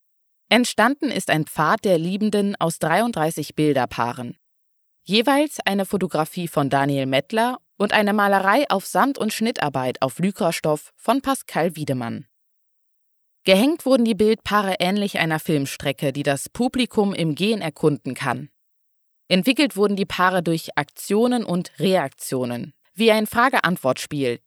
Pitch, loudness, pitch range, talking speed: 185 Hz, -21 LUFS, 150-215 Hz, 130 wpm